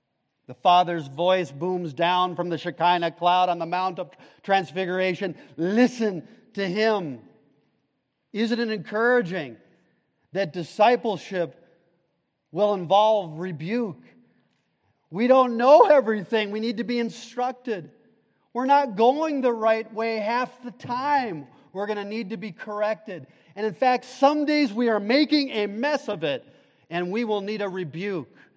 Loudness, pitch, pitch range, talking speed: -24 LUFS, 210 Hz, 175-235 Hz, 145 wpm